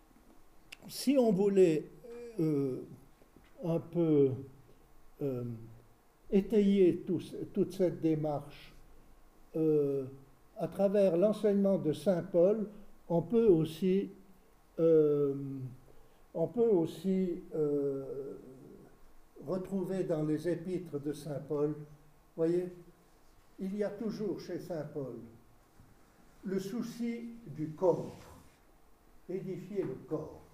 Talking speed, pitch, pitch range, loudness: 100 wpm, 165 Hz, 145-190 Hz, -33 LUFS